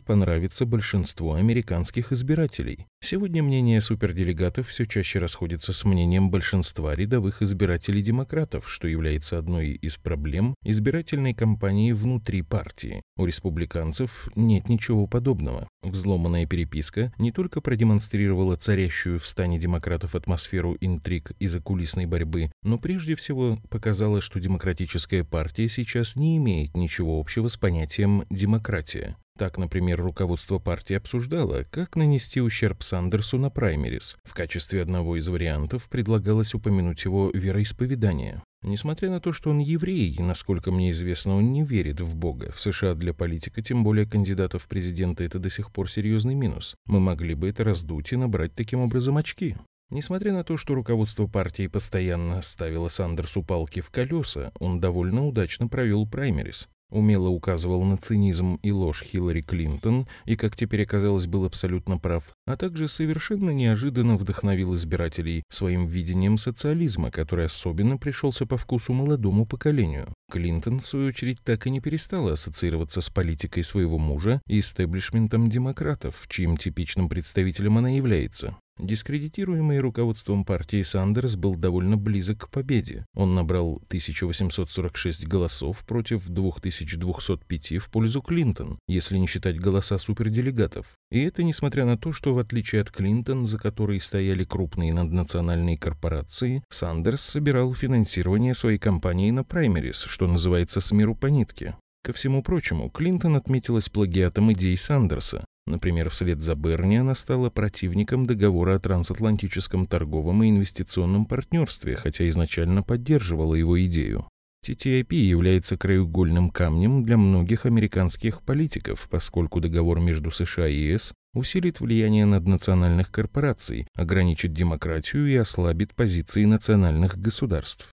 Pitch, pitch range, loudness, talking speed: 100 Hz, 90-115 Hz, -25 LUFS, 135 wpm